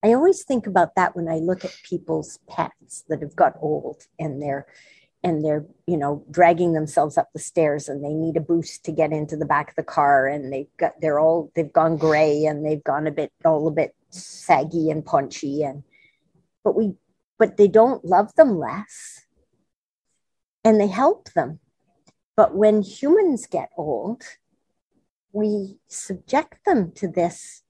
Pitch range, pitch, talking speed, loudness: 155-205 Hz, 165 Hz, 175 wpm, -21 LUFS